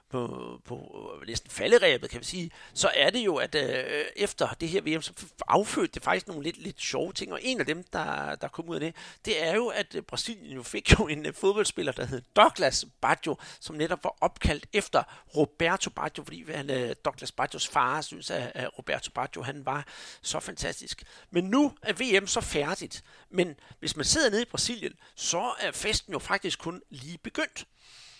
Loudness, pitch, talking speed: -29 LUFS, 225 Hz, 200 wpm